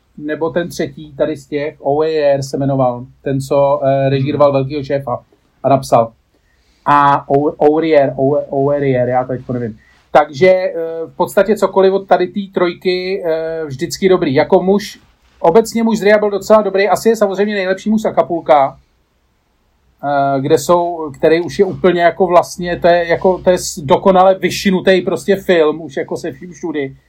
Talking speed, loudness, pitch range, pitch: 155 wpm, -14 LUFS, 140-185 Hz, 165 Hz